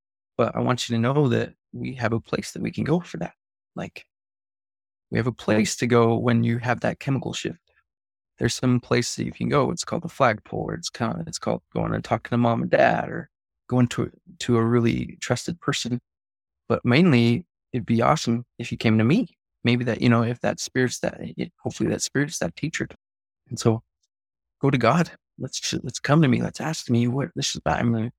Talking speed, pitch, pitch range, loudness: 215 wpm, 120 Hz, 110-125 Hz, -24 LUFS